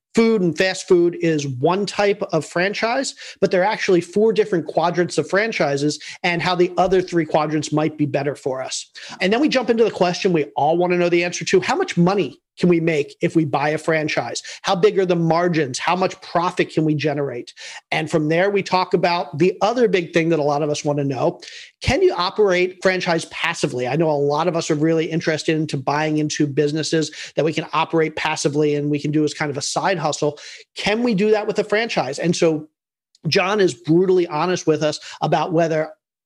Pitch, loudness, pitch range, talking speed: 170 Hz, -19 LUFS, 155-190 Hz, 220 wpm